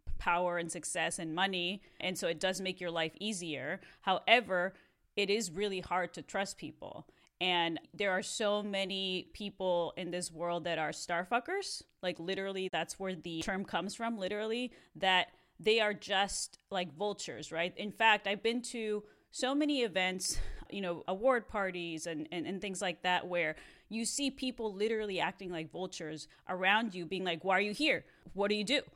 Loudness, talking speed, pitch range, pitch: -35 LUFS, 180 wpm, 175-210 Hz, 185 Hz